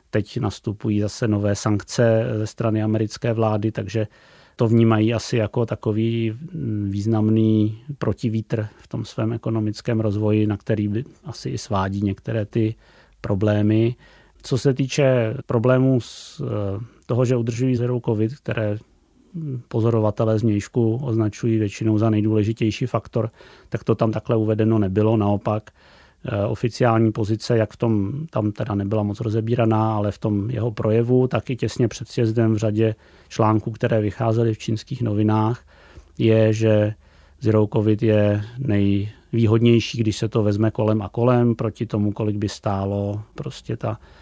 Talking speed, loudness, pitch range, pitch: 140 wpm, -21 LUFS, 105-115 Hz, 110 Hz